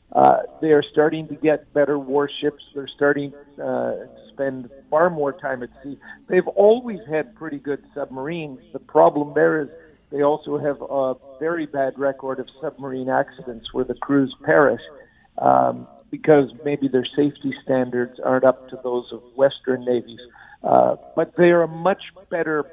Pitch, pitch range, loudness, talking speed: 140 Hz, 130-155 Hz, -21 LUFS, 160 wpm